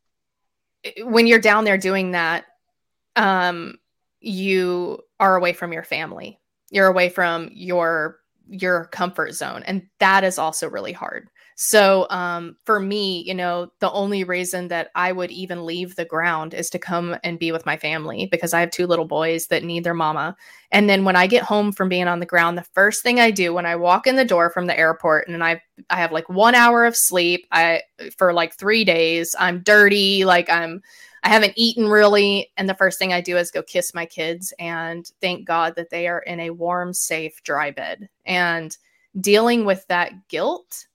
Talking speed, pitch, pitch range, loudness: 200 wpm, 180 Hz, 170-195 Hz, -19 LUFS